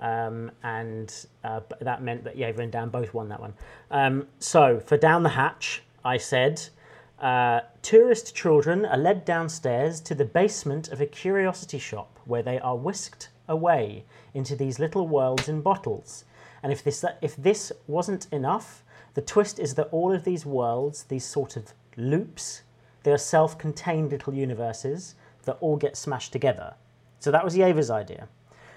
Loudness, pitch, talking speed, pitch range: -26 LUFS, 145 Hz, 165 wpm, 120-160 Hz